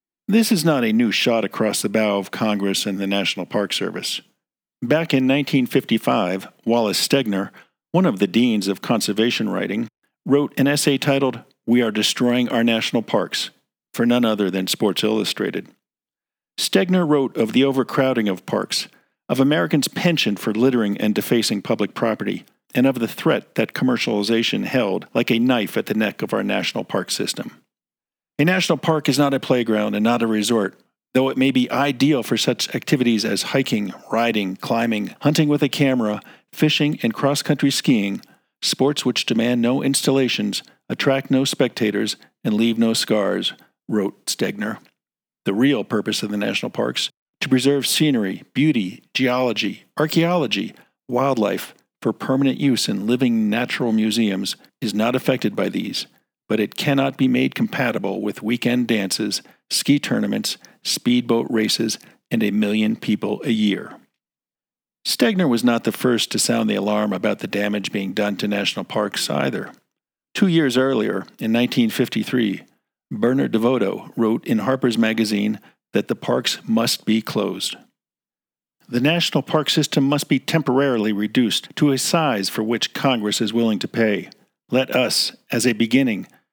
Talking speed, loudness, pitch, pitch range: 155 wpm, -20 LUFS, 120 Hz, 110-140 Hz